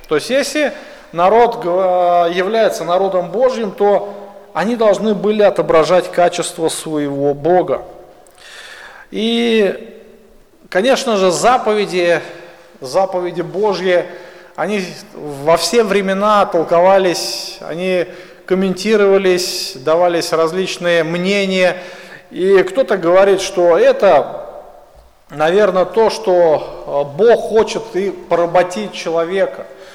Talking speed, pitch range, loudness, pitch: 90 wpm, 175-210 Hz, -14 LUFS, 185 Hz